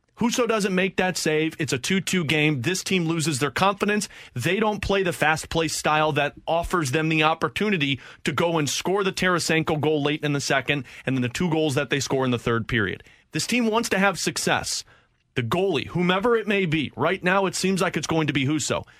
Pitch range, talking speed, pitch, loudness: 150-190 Hz, 225 wpm, 160 Hz, -23 LUFS